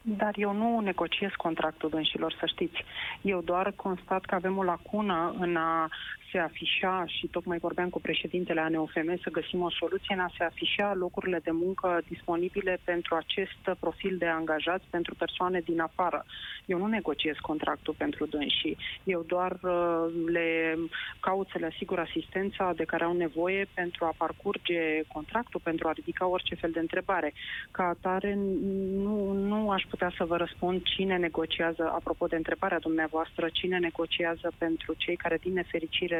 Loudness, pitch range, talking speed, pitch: -31 LUFS, 165-185 Hz, 160 wpm, 175 Hz